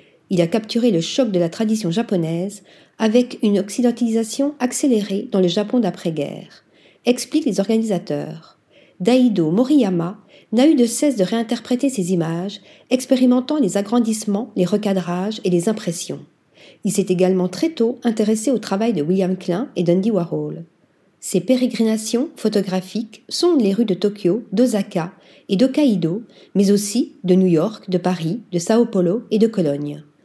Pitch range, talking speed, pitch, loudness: 185-240 Hz, 150 wpm, 210 Hz, -19 LUFS